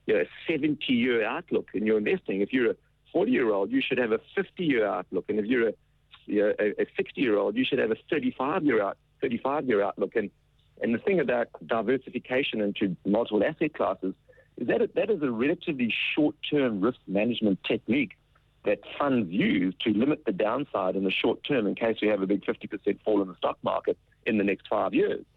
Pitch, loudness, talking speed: 130 Hz, -27 LUFS, 190 wpm